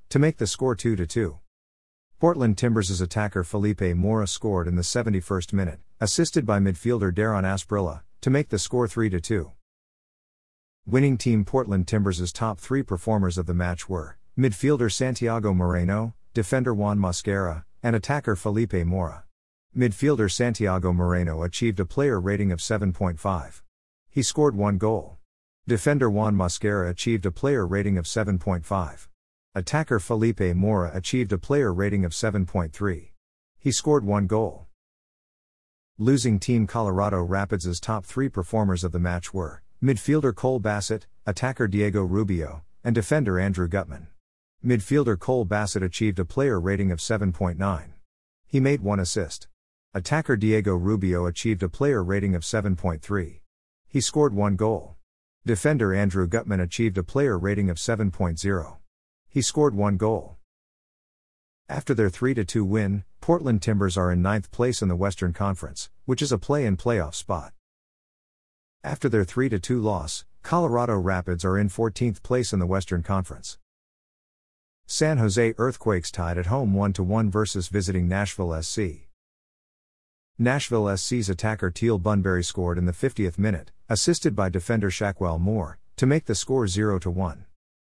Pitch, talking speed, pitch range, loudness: 100 Hz, 140 wpm, 90-115 Hz, -25 LUFS